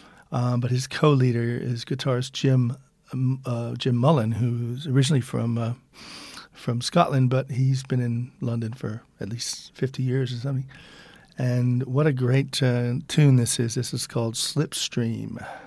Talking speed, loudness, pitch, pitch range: 155 wpm, -24 LUFS, 130 Hz, 120-135 Hz